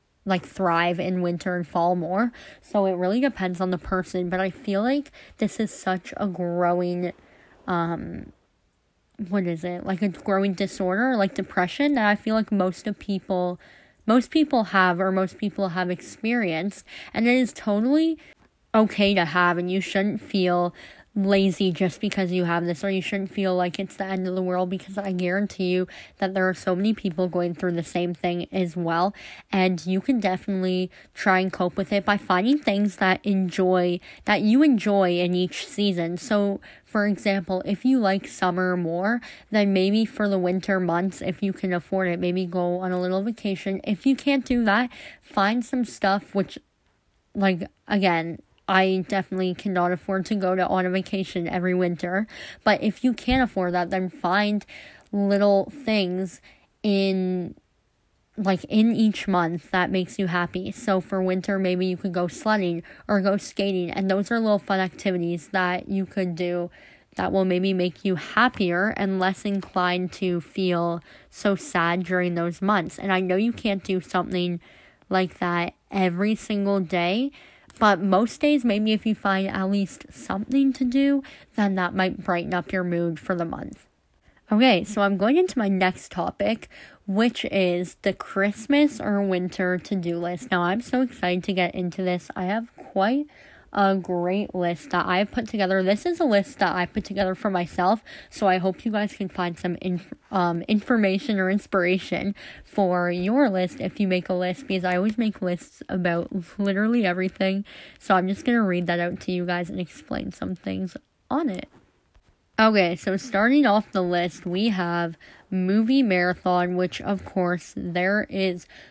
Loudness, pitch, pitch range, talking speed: -24 LUFS, 190 Hz, 180-205 Hz, 180 wpm